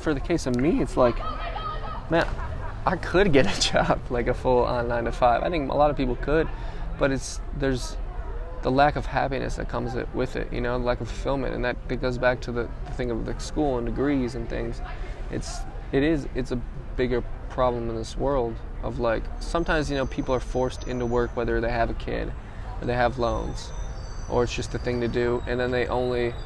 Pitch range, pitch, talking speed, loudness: 120-130 Hz, 125 Hz, 220 wpm, -26 LUFS